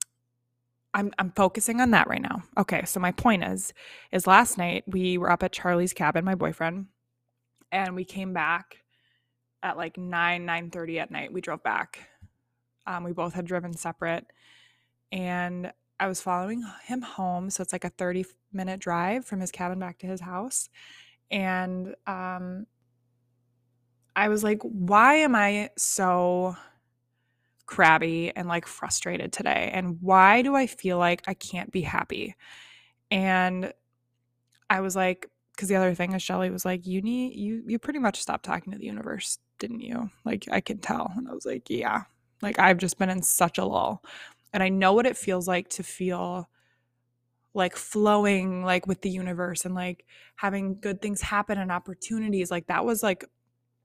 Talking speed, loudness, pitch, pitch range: 175 wpm, -26 LUFS, 185 Hz, 170-195 Hz